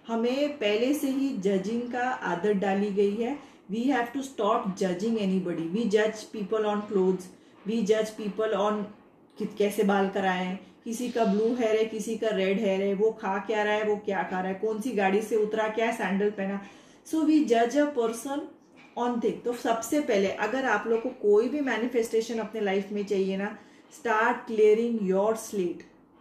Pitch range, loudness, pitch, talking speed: 205-240 Hz, -27 LUFS, 220 Hz, 195 wpm